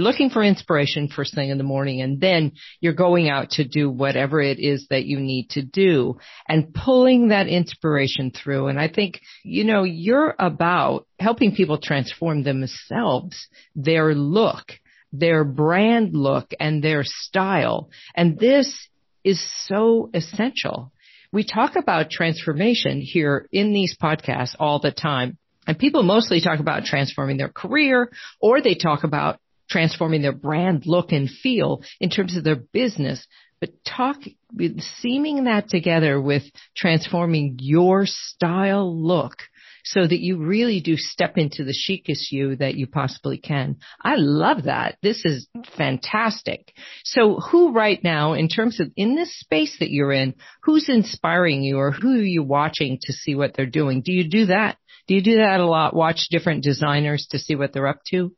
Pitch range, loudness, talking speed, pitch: 140-195 Hz, -20 LUFS, 165 wpm, 165 Hz